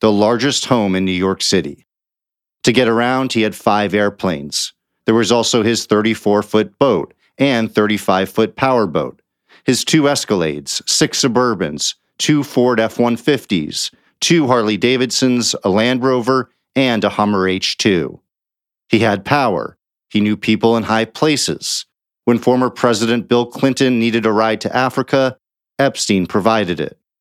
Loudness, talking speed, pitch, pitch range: -16 LUFS, 150 wpm, 115 Hz, 105-125 Hz